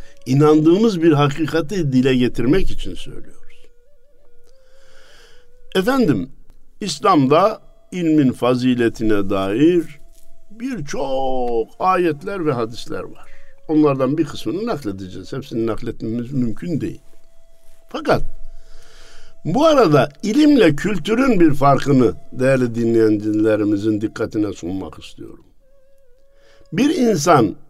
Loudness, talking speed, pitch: -17 LUFS, 85 wpm, 150 Hz